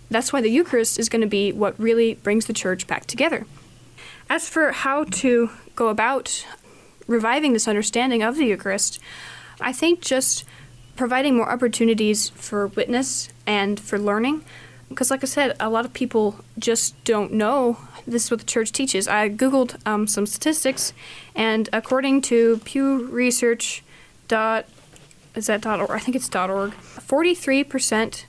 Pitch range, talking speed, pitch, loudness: 210-260 Hz, 160 wpm, 230 Hz, -21 LUFS